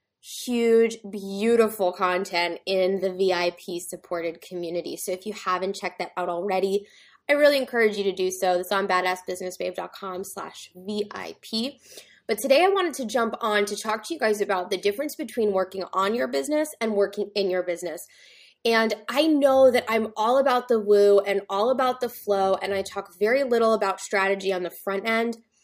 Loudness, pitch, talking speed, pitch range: -24 LUFS, 200 Hz, 180 wpm, 185-230 Hz